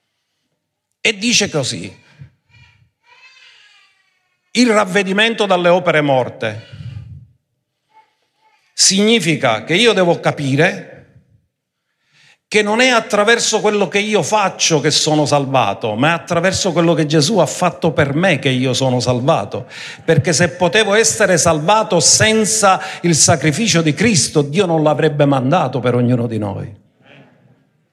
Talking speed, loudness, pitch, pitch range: 120 wpm, -14 LUFS, 170 Hz, 140-210 Hz